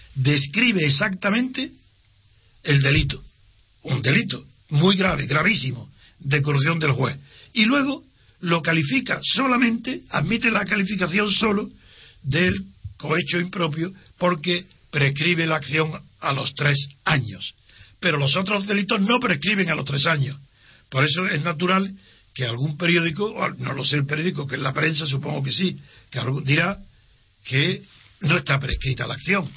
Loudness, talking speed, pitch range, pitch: -21 LUFS, 140 wpm, 135-185 Hz, 150 Hz